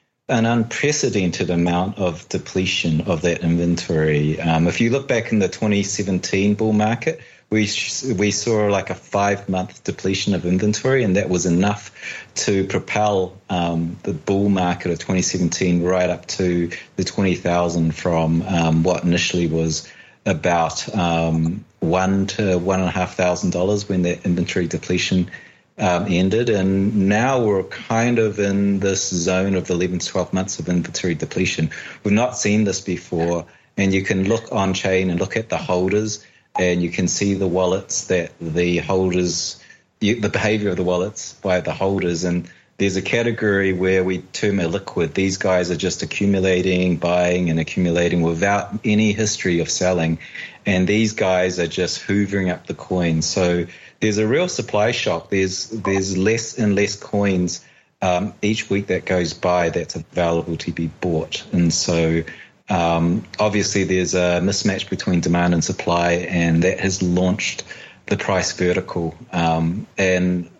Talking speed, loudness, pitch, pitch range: 165 wpm, -20 LUFS, 95 Hz, 85-100 Hz